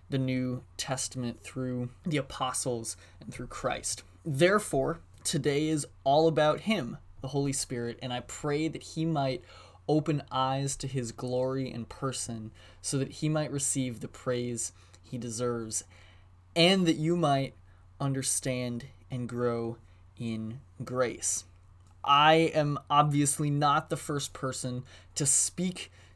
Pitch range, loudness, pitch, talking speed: 110-145 Hz, -30 LUFS, 130 Hz, 135 wpm